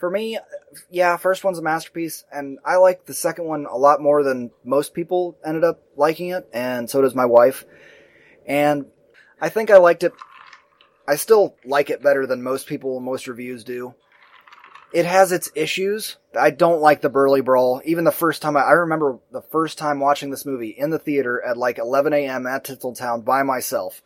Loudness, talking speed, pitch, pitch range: -19 LUFS, 195 wpm, 145 Hz, 135-170 Hz